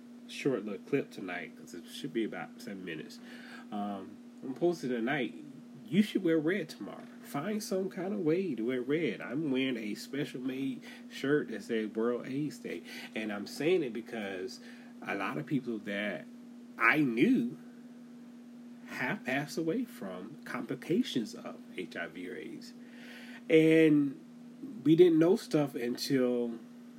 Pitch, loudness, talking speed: 220 Hz, -32 LUFS, 145 wpm